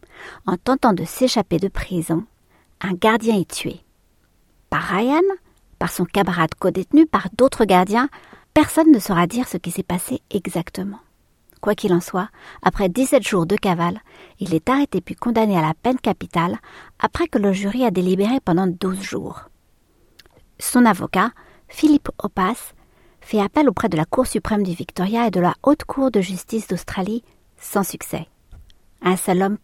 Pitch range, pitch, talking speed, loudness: 180-245 Hz, 200 Hz, 165 wpm, -20 LUFS